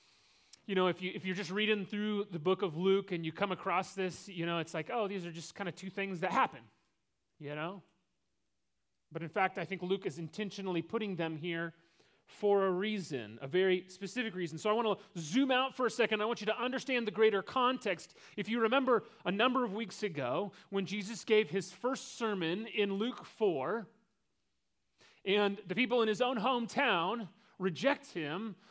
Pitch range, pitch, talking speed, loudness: 180-225 Hz, 200 Hz, 200 wpm, -34 LUFS